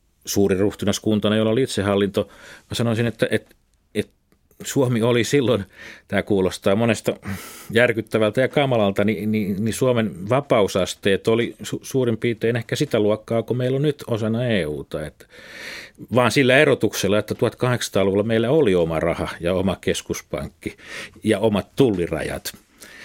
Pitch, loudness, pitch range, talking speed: 110 Hz, -21 LUFS, 105-120 Hz, 140 wpm